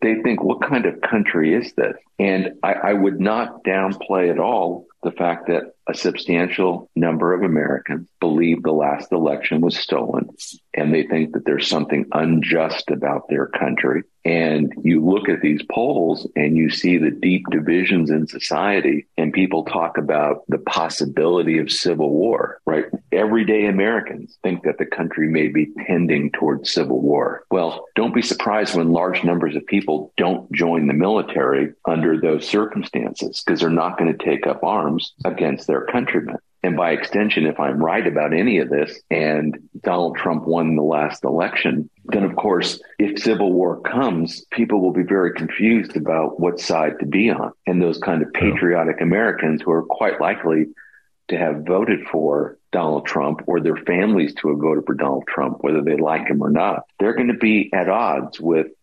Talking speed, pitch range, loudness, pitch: 180 wpm, 80-95 Hz, -19 LUFS, 85 Hz